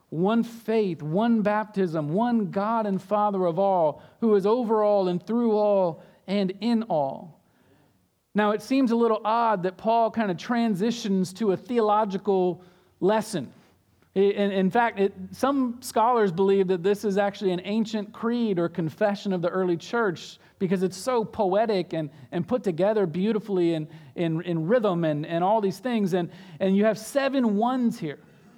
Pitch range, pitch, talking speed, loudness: 185-225 Hz, 200 Hz, 170 wpm, -25 LUFS